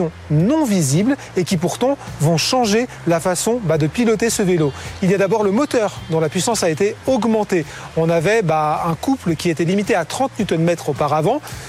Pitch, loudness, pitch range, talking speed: 185 Hz, -18 LUFS, 160-225 Hz, 185 wpm